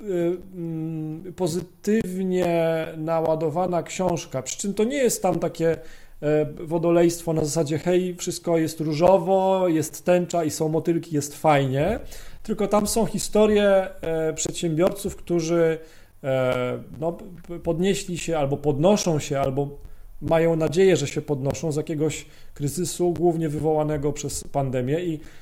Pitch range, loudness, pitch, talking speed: 155-180 Hz, -23 LUFS, 165 Hz, 120 wpm